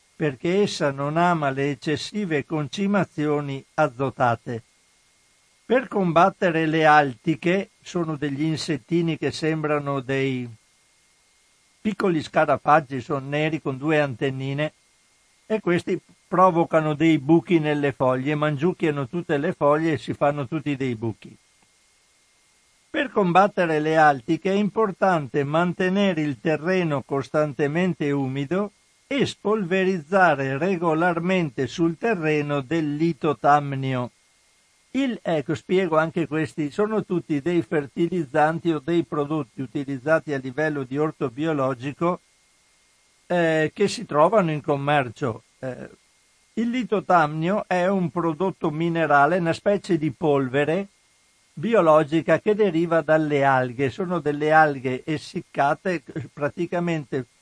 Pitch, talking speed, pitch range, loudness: 155 Hz, 110 wpm, 145-175 Hz, -23 LUFS